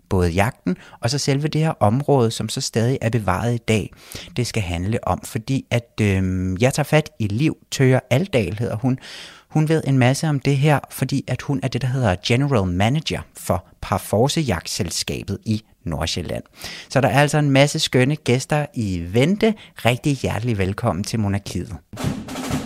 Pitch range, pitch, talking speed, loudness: 105-135 Hz, 120 Hz, 170 wpm, -21 LUFS